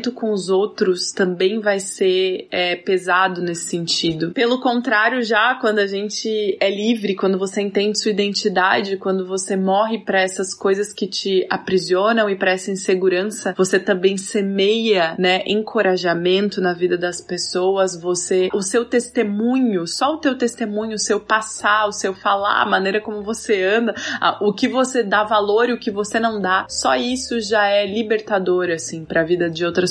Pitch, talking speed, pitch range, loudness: 200 Hz, 175 wpm, 185-220 Hz, -19 LUFS